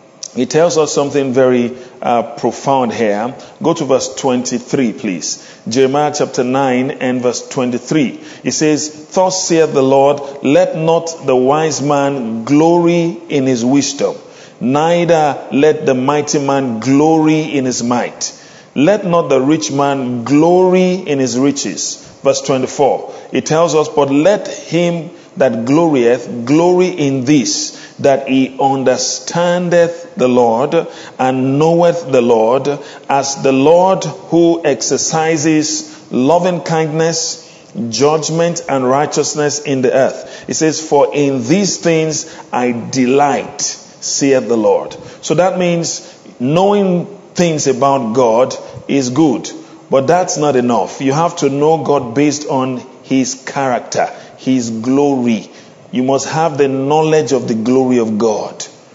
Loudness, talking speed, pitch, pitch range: -13 LUFS, 135 wpm, 145 Hz, 130-165 Hz